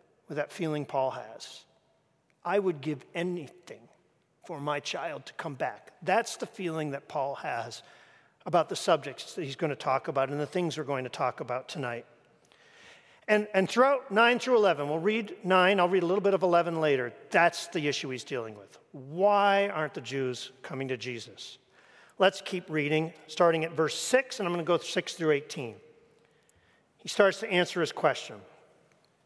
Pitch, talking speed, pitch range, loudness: 160 Hz, 185 wpm, 140-190 Hz, -29 LUFS